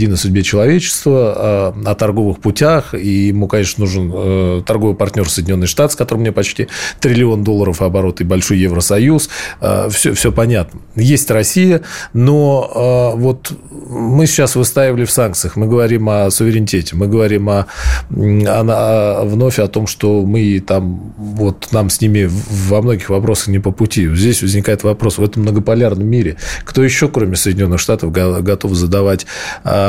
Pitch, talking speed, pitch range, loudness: 105 Hz, 150 wpm, 95-115 Hz, -13 LUFS